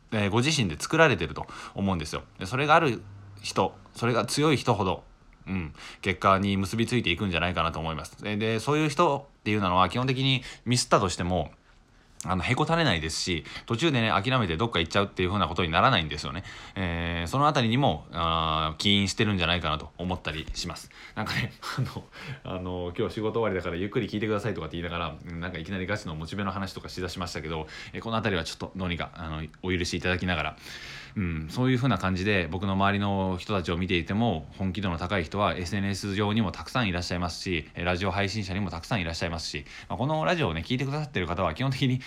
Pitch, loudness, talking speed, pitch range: 95 Hz, -27 LUFS, 490 characters per minute, 85-110 Hz